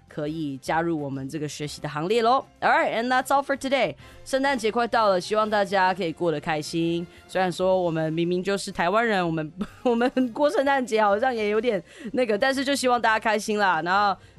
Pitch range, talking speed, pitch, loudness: 170-245 Hz, 400 characters per minute, 205 Hz, -24 LUFS